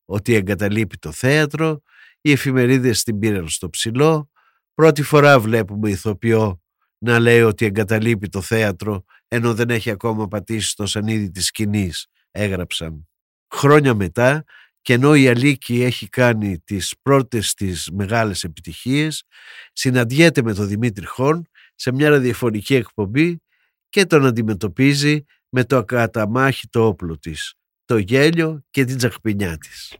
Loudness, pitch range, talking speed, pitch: -18 LUFS, 105-135 Hz, 135 wpm, 115 Hz